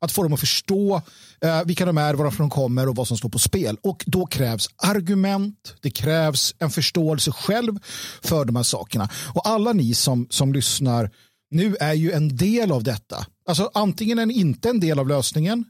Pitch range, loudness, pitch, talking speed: 130-195 Hz, -21 LUFS, 155 Hz, 205 wpm